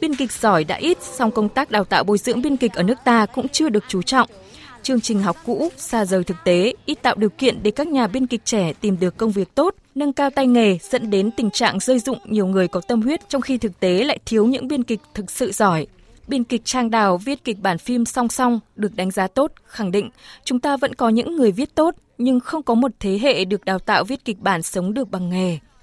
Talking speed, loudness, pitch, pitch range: 260 wpm, -20 LUFS, 230 Hz, 200-260 Hz